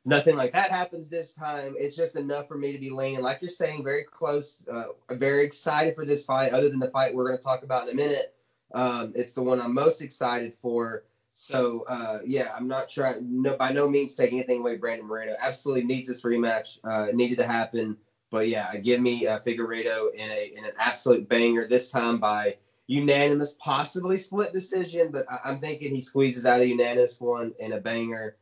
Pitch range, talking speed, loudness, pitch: 120-145 Hz, 215 wpm, -27 LUFS, 130 Hz